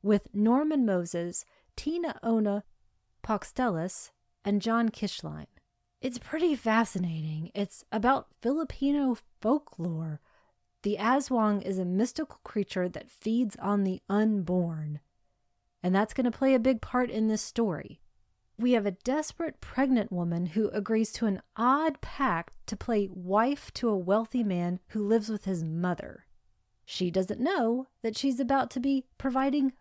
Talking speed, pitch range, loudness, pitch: 145 wpm, 185-255 Hz, -30 LUFS, 215 Hz